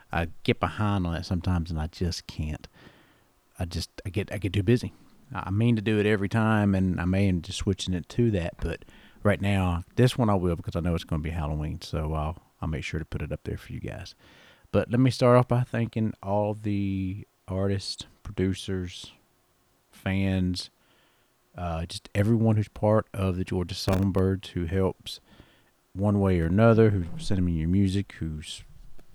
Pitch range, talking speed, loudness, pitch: 90-105 Hz, 195 wpm, -27 LUFS, 95 Hz